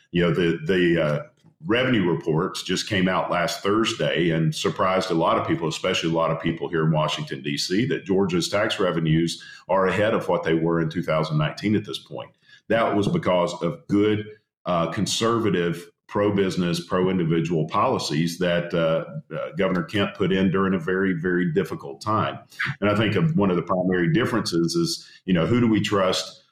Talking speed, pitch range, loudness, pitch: 185 wpm, 80-95 Hz, -23 LUFS, 85 Hz